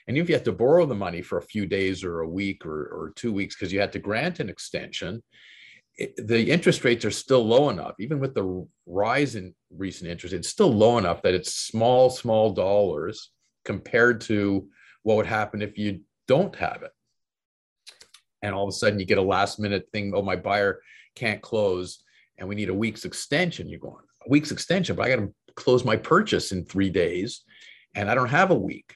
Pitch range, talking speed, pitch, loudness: 95-115 Hz, 215 wpm, 105 Hz, -24 LUFS